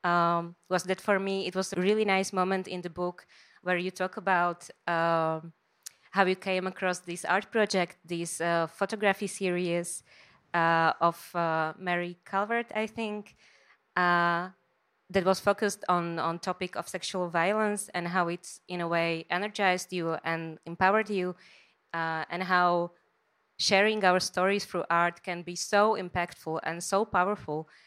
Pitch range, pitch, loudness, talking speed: 170-190 Hz, 180 Hz, -29 LUFS, 155 wpm